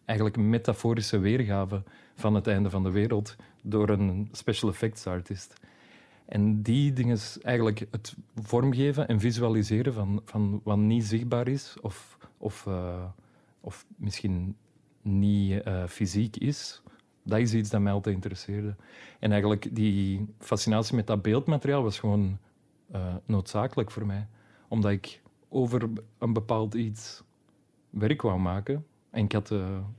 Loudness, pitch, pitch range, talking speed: -29 LUFS, 105 Hz, 100-115 Hz, 145 wpm